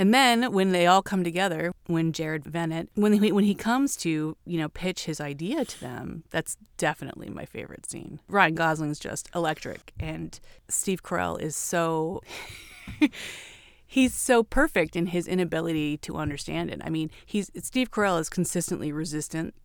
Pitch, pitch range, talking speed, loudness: 170 Hz, 155-195 Hz, 165 wpm, -26 LUFS